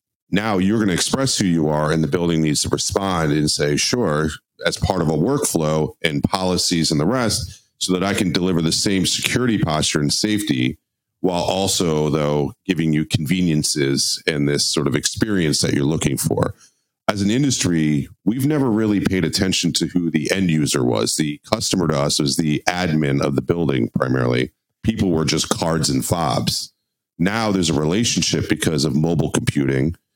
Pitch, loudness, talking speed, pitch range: 85 Hz, -19 LUFS, 185 wpm, 75-100 Hz